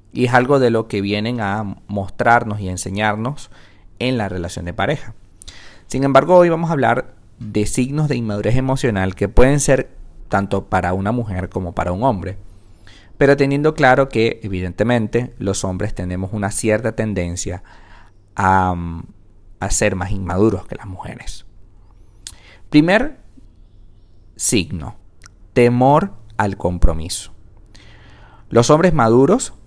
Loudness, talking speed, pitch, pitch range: -17 LUFS, 130 wpm, 105 Hz, 95-120 Hz